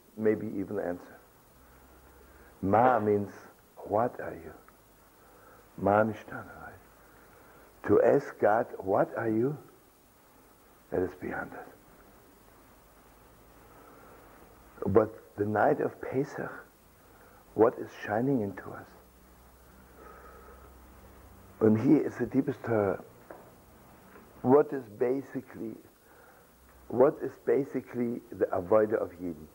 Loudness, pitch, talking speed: -29 LUFS, 100 Hz, 95 wpm